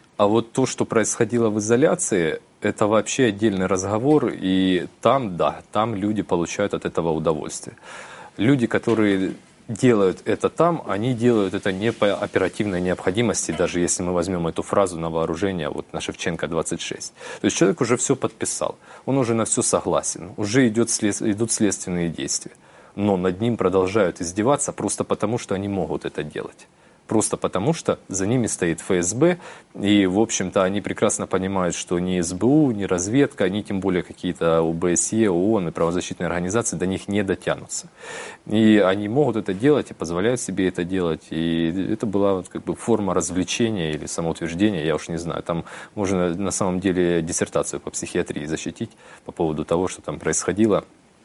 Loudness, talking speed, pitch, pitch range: -22 LUFS, 165 wpm, 100 Hz, 90-110 Hz